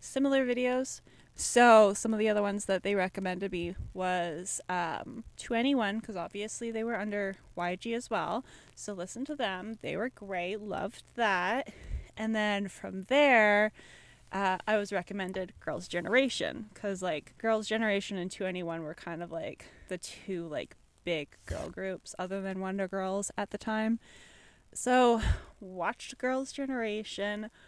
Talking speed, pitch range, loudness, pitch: 155 wpm, 185-225 Hz, -31 LUFS, 205 Hz